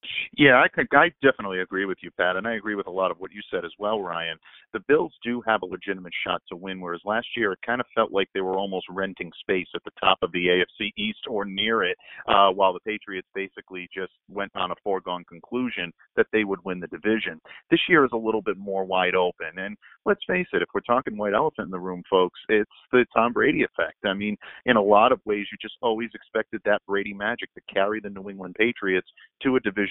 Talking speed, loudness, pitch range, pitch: 245 wpm, -24 LUFS, 95-110 Hz, 100 Hz